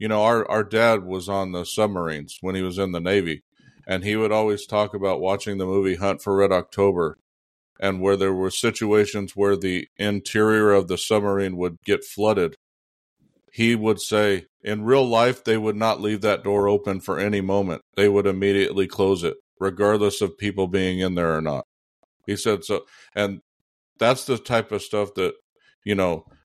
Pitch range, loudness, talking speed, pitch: 95-105 Hz, -22 LUFS, 190 wpm, 100 Hz